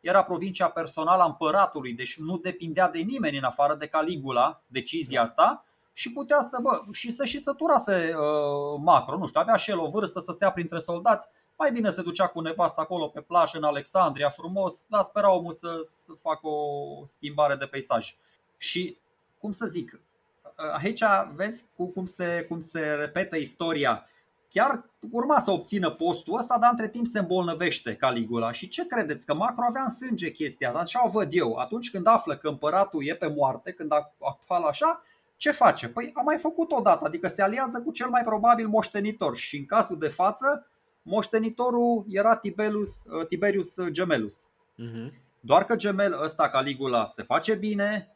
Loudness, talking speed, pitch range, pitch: -26 LUFS, 180 wpm, 155-225 Hz, 185 Hz